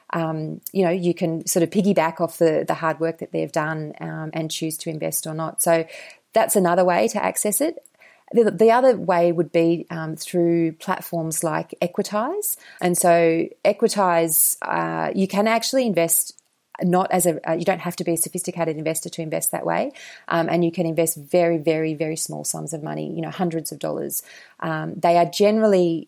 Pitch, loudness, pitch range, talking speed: 170 Hz, -21 LUFS, 160-185 Hz, 200 wpm